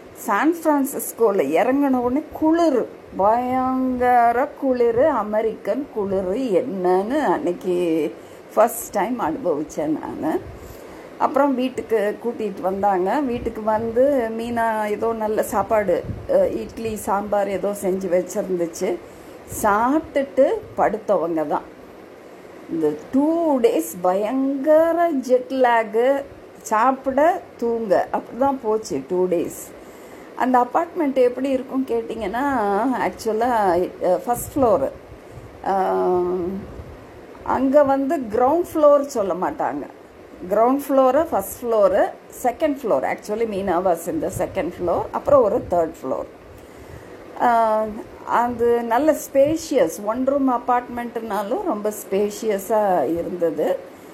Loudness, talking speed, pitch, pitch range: -21 LUFS, 90 wpm, 235 Hz, 205-275 Hz